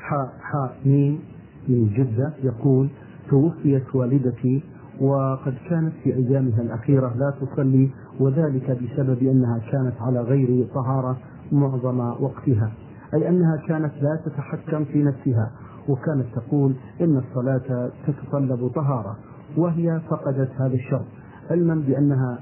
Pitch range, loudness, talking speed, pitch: 130-145 Hz, -23 LUFS, 110 wpm, 135 Hz